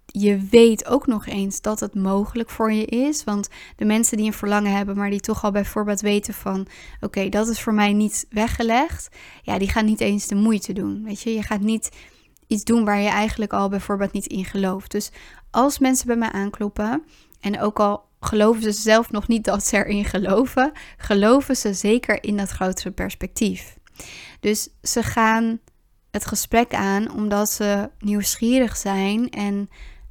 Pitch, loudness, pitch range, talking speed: 210 Hz, -21 LUFS, 200-225 Hz, 185 wpm